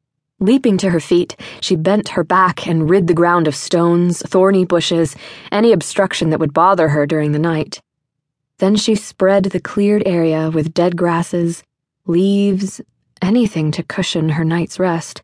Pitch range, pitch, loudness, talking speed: 160-190 Hz, 175 Hz, -15 LUFS, 160 wpm